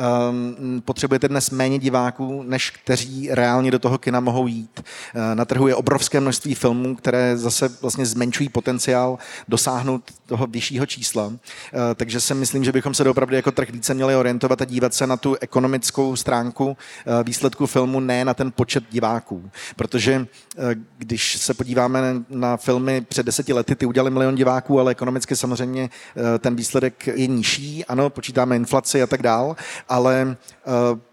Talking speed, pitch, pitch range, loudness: 155 wpm, 130 Hz, 120-135 Hz, -21 LUFS